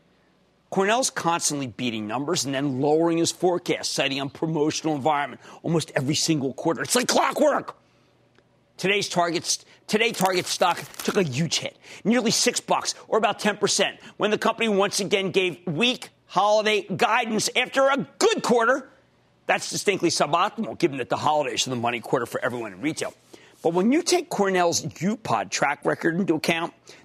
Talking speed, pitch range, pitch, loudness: 160 wpm, 155-210 Hz, 180 Hz, -23 LUFS